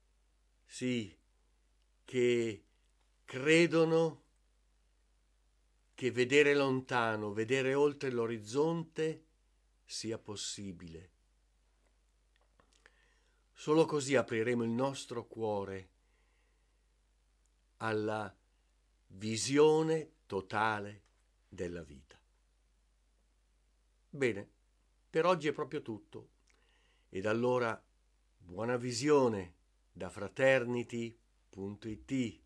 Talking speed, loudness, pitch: 65 wpm, -33 LUFS, 105 Hz